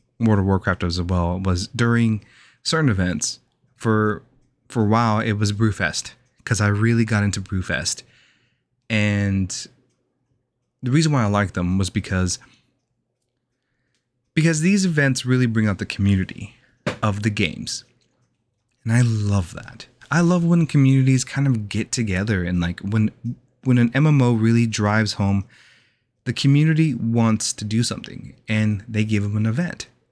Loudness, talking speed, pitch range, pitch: -21 LUFS, 150 wpm, 105-125 Hz, 115 Hz